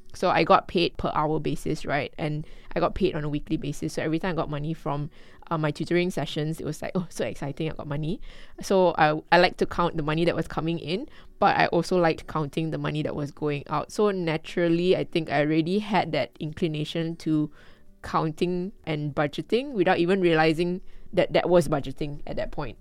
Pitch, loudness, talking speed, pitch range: 165 Hz, -26 LUFS, 215 wpm, 150-175 Hz